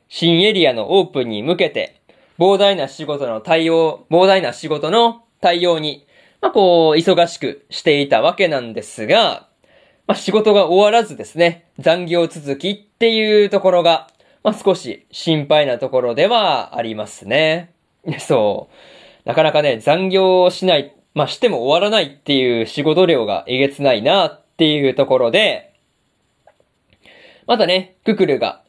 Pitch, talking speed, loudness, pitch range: 170 Hz, 295 characters per minute, -16 LUFS, 150-195 Hz